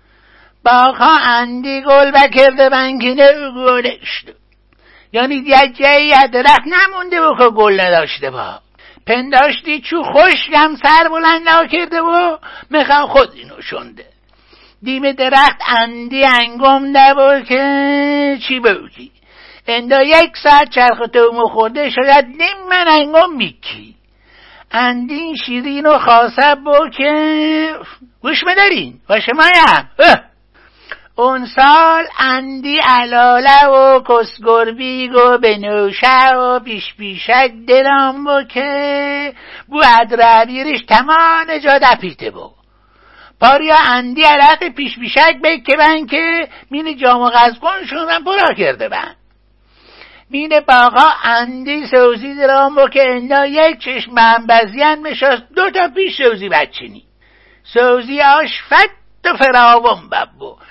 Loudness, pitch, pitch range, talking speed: -10 LUFS, 275 Hz, 245-310 Hz, 120 wpm